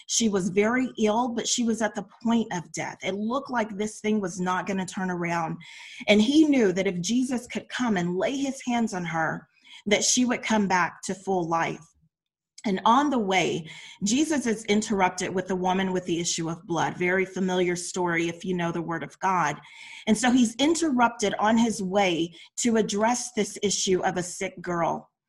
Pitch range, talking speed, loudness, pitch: 180-230 Hz, 200 wpm, -25 LUFS, 195 Hz